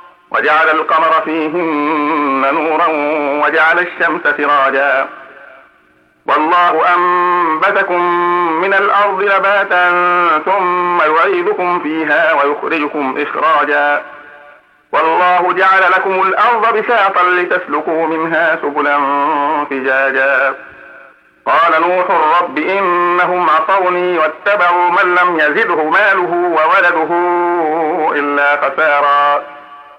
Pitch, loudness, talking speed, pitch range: 175 Hz, -12 LUFS, 80 wpm, 145-180 Hz